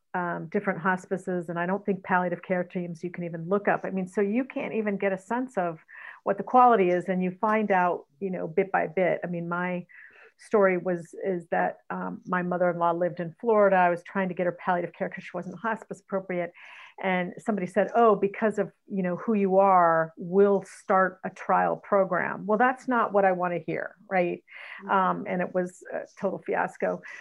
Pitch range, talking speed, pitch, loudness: 180-200 Hz, 210 wpm, 190 Hz, -27 LUFS